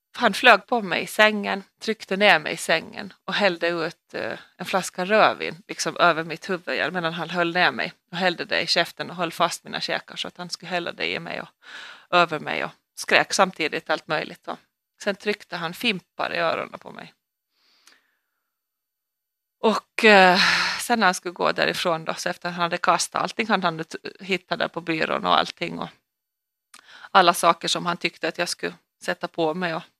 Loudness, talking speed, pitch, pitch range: -22 LUFS, 195 wpm, 180 Hz, 170-200 Hz